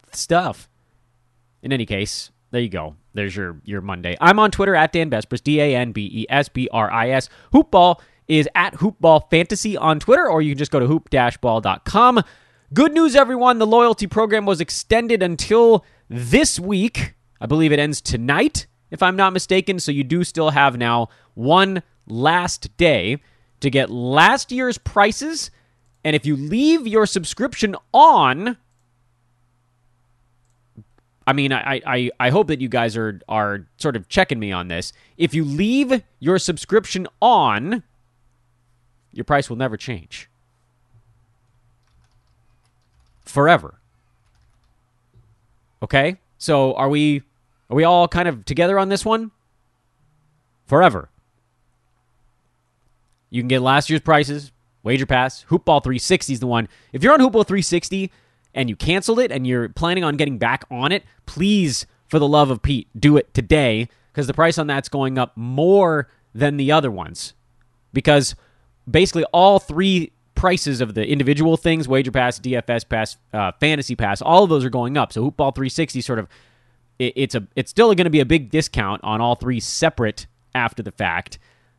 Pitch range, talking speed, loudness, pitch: 120-170 Hz, 165 wpm, -18 LUFS, 135 Hz